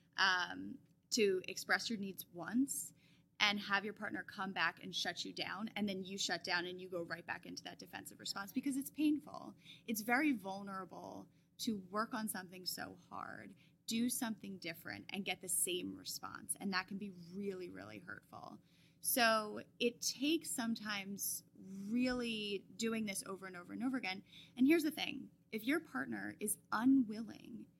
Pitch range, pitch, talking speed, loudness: 180-230 Hz, 200 Hz, 170 wpm, -39 LUFS